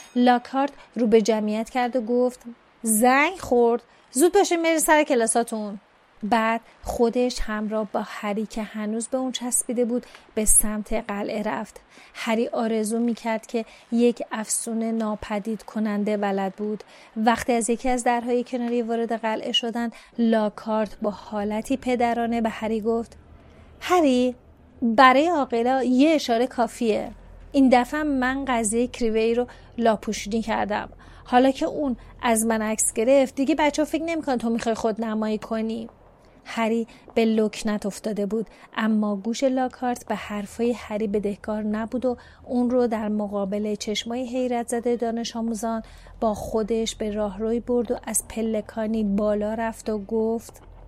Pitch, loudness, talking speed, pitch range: 230 Hz, -24 LUFS, 140 wpm, 220-245 Hz